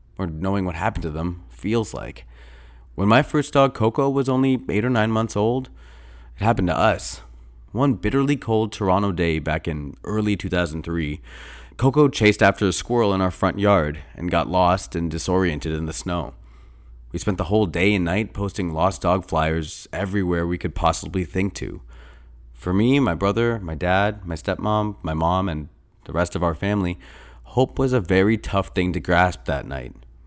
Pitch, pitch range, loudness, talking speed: 90 Hz, 80-105 Hz, -22 LUFS, 185 wpm